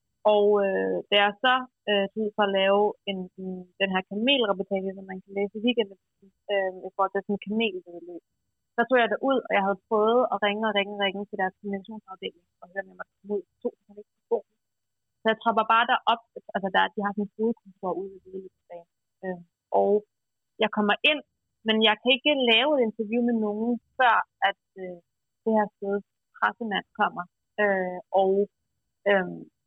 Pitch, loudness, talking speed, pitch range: 205 Hz, -25 LUFS, 185 wpm, 190-220 Hz